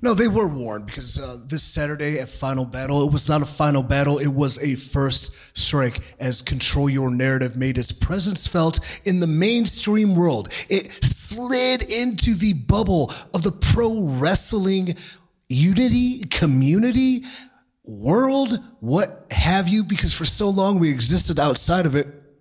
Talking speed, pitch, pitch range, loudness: 155 wpm, 165 Hz, 135-205 Hz, -21 LUFS